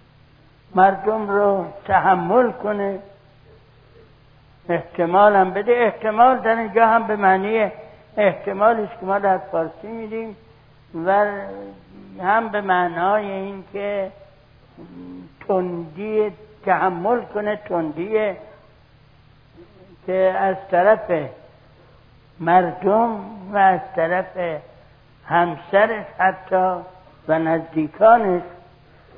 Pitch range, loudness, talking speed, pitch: 150-205 Hz, -19 LUFS, 80 wpm, 185 Hz